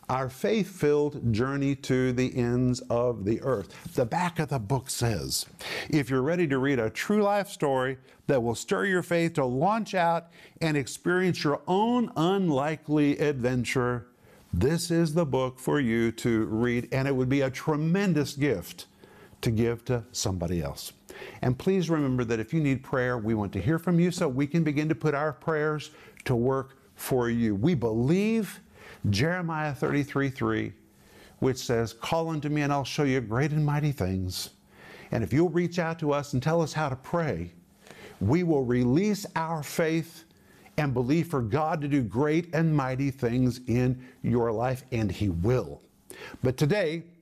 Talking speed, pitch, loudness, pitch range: 175 wpm, 140 Hz, -27 LUFS, 125-160 Hz